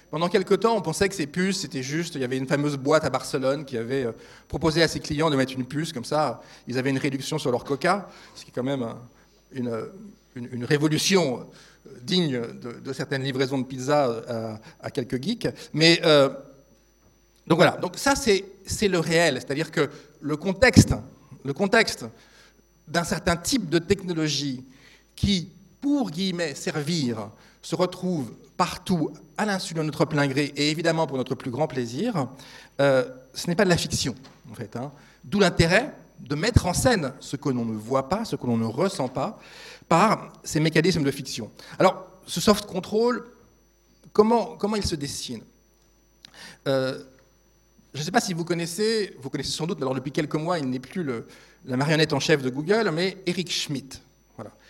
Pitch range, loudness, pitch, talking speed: 135-180 Hz, -25 LUFS, 155 Hz, 185 wpm